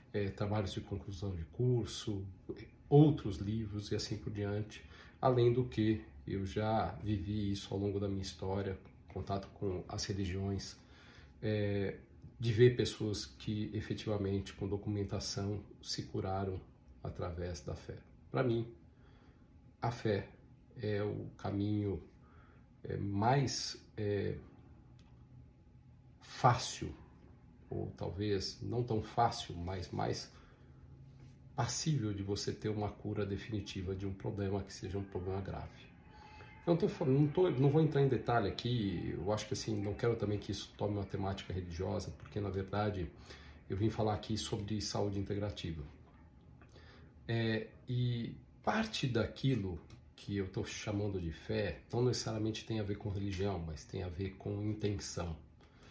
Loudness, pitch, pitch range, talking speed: -37 LUFS, 105 Hz, 95-110 Hz, 140 wpm